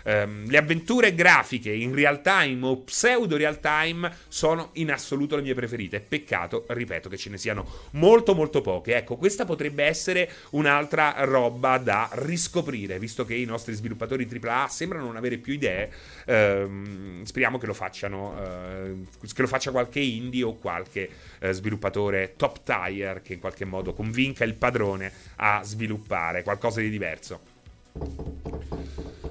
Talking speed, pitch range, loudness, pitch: 150 wpm, 100-145 Hz, -25 LUFS, 120 Hz